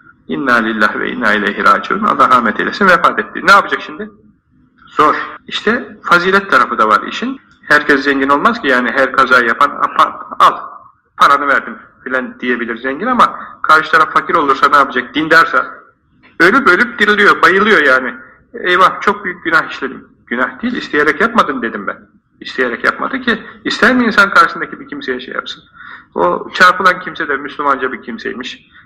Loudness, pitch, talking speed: -11 LUFS, 180 Hz, 165 wpm